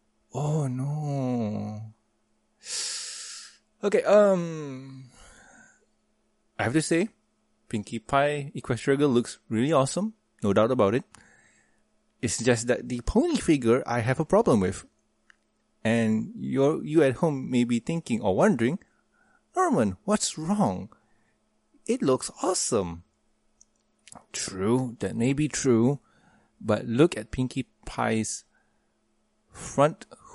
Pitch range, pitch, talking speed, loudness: 110-165 Hz, 130 Hz, 115 wpm, -26 LUFS